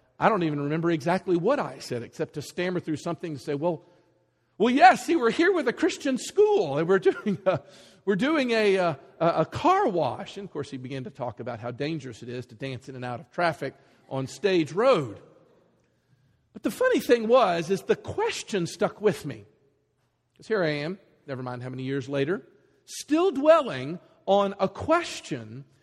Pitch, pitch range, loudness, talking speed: 170 Hz, 140-215 Hz, -26 LUFS, 195 wpm